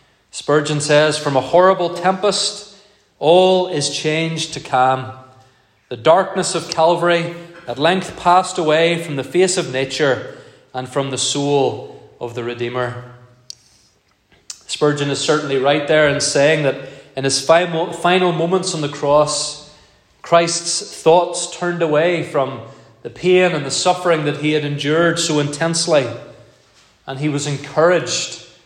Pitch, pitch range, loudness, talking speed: 150 Hz, 135-170 Hz, -17 LUFS, 140 wpm